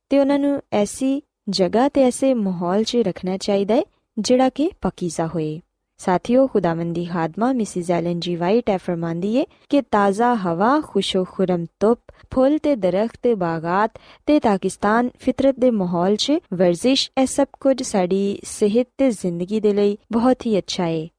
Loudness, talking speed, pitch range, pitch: -20 LUFS, 150 wpm, 185-260 Hz, 210 Hz